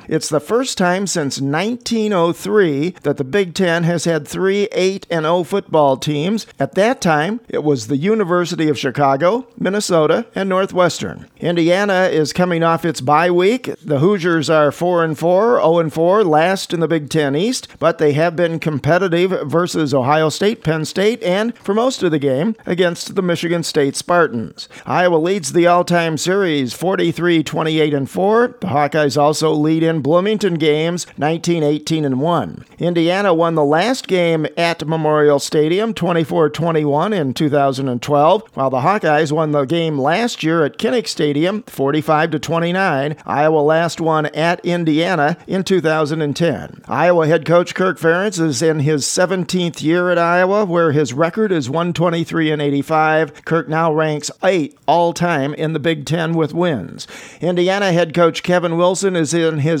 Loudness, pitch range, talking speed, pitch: -16 LUFS, 155-180 Hz, 160 wpm, 165 Hz